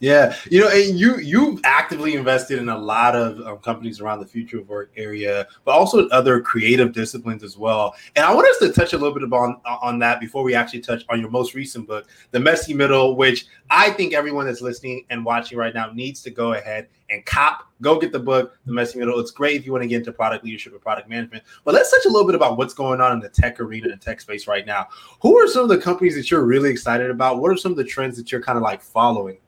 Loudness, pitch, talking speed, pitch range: -18 LUFS, 125 Hz, 265 wpm, 115-140 Hz